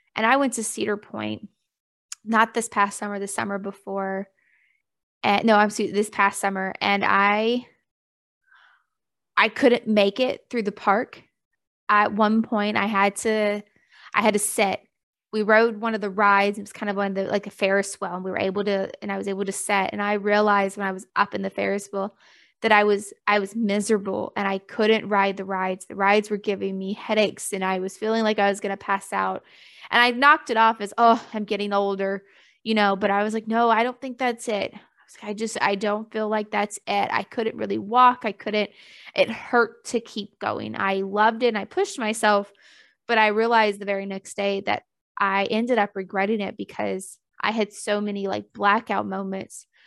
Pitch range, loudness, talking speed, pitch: 200-220 Hz, -23 LUFS, 215 wpm, 205 Hz